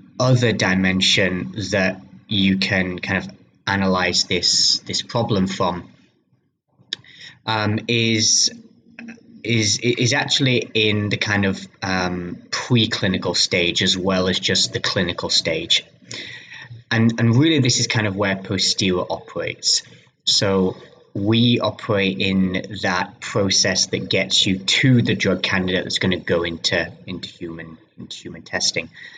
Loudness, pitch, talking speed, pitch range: -19 LUFS, 100 Hz, 130 wpm, 95-115 Hz